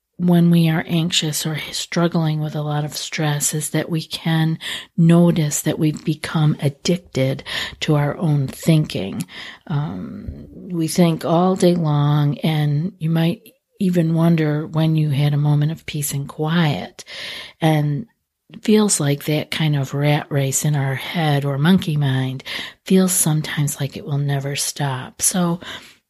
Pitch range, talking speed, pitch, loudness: 145-170 Hz, 155 wpm, 155 Hz, -19 LUFS